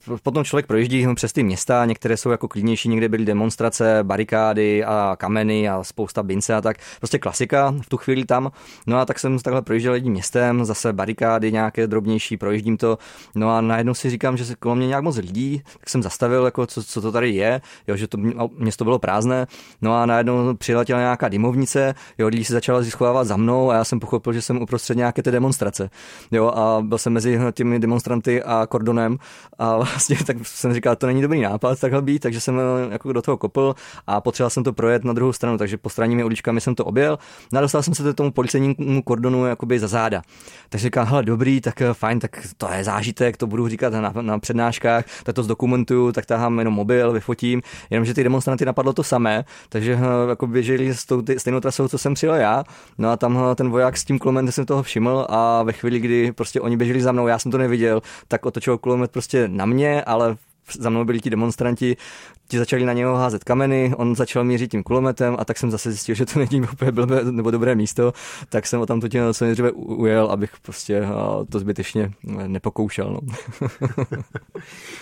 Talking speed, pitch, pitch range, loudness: 205 wpm, 120 Hz, 115-125 Hz, -20 LUFS